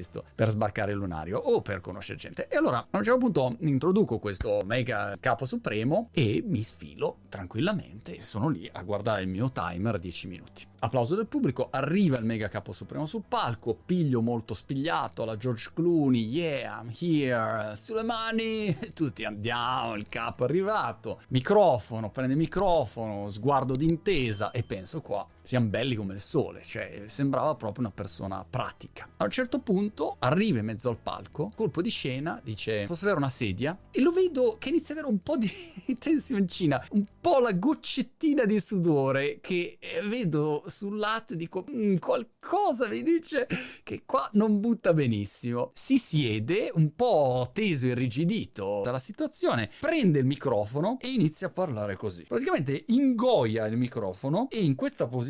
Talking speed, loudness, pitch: 165 wpm, -29 LUFS, 140 Hz